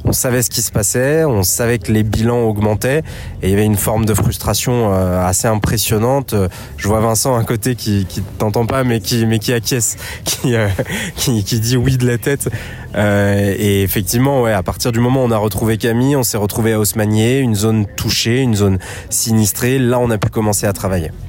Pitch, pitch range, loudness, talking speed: 110 Hz, 105-120 Hz, -15 LUFS, 215 wpm